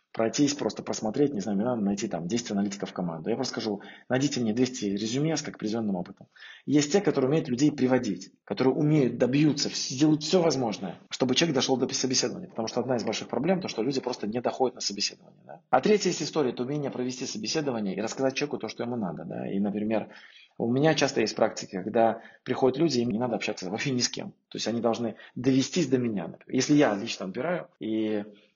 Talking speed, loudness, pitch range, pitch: 215 wpm, -27 LUFS, 110-140 Hz, 125 Hz